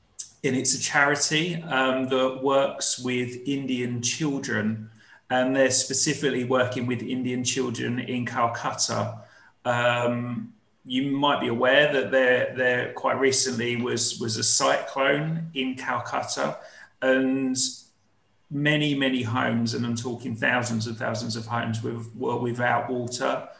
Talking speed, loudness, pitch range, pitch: 130 wpm, -24 LUFS, 120-135 Hz, 125 Hz